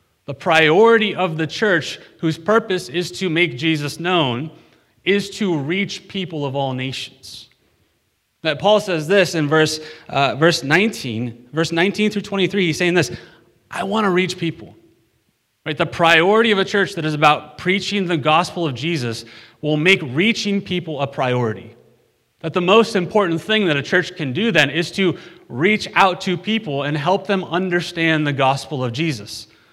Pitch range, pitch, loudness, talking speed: 145-190 Hz, 165 Hz, -18 LUFS, 170 wpm